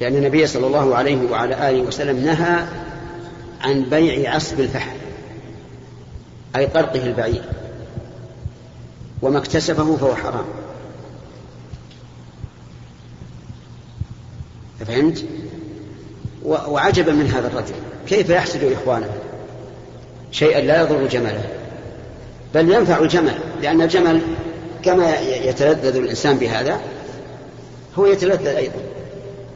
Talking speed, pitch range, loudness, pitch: 90 wpm, 125-160 Hz, -18 LUFS, 140 Hz